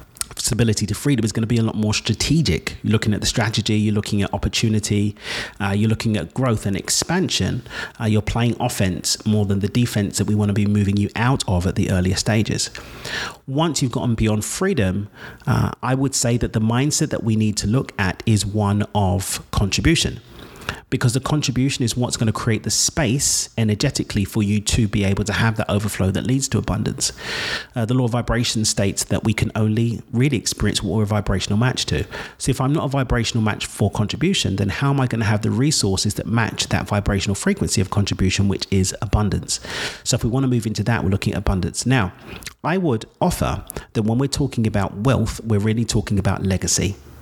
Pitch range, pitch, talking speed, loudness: 100-120 Hz, 110 Hz, 210 wpm, -20 LUFS